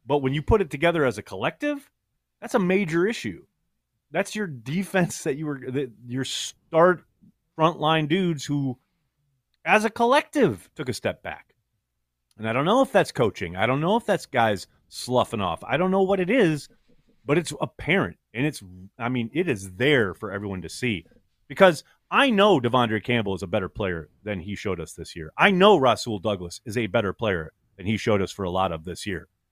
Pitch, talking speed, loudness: 135 Hz, 205 wpm, -24 LUFS